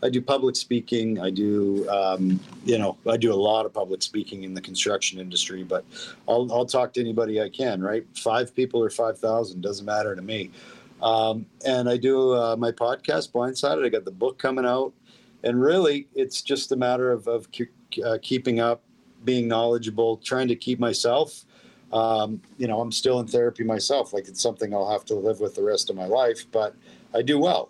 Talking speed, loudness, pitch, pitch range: 200 wpm, -25 LUFS, 120 Hz, 110-130 Hz